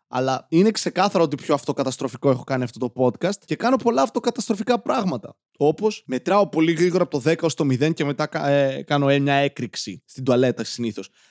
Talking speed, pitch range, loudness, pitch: 185 wpm, 130-180 Hz, -22 LUFS, 145 Hz